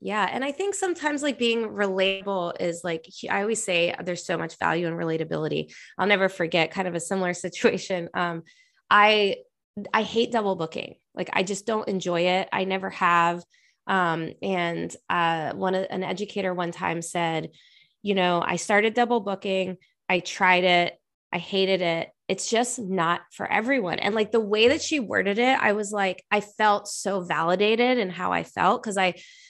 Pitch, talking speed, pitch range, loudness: 190 Hz, 180 wpm, 175-215 Hz, -24 LUFS